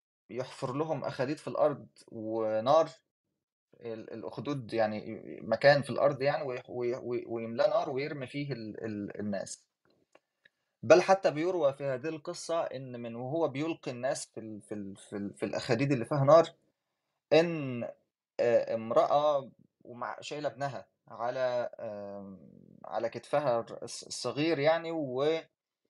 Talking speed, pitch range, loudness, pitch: 115 wpm, 115-155 Hz, -31 LUFS, 130 Hz